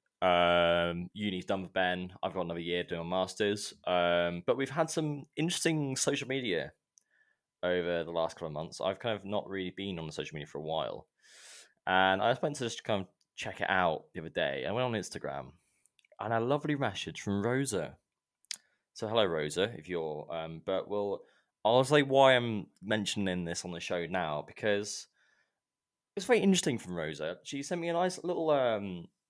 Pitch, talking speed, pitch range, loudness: 100 Hz, 195 wpm, 90-135 Hz, -32 LUFS